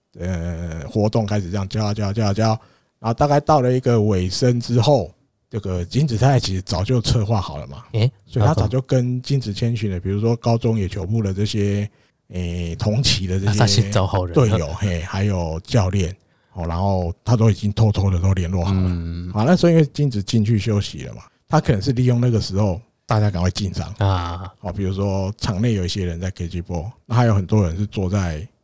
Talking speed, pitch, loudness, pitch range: 310 characters per minute, 105 Hz, -20 LUFS, 95-120 Hz